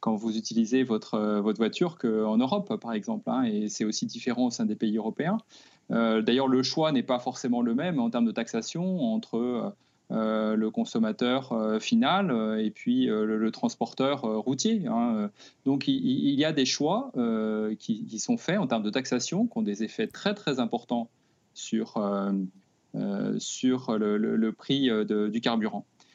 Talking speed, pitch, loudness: 190 wpm, 130 Hz, -28 LUFS